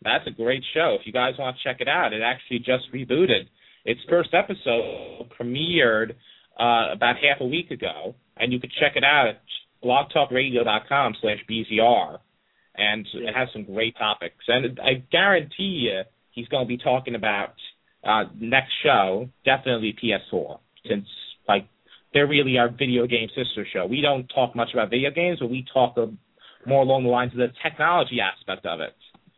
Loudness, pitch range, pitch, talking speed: -23 LUFS, 115-135 Hz, 125 Hz, 180 wpm